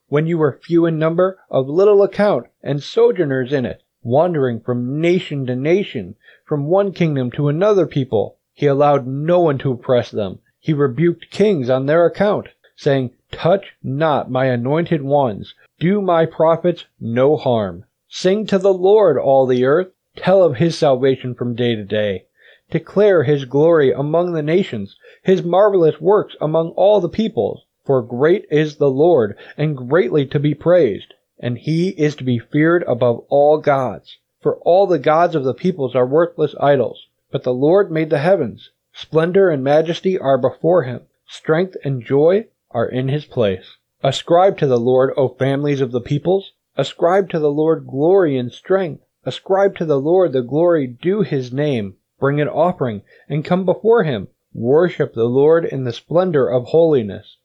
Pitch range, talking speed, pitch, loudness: 130-175 Hz, 170 wpm, 150 Hz, -17 LUFS